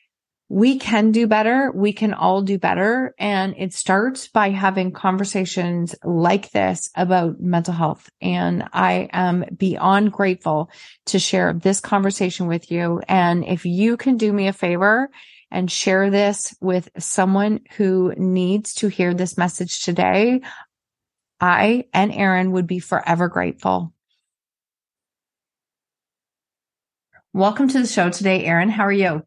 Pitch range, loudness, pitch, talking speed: 175-205 Hz, -19 LUFS, 190 Hz, 135 wpm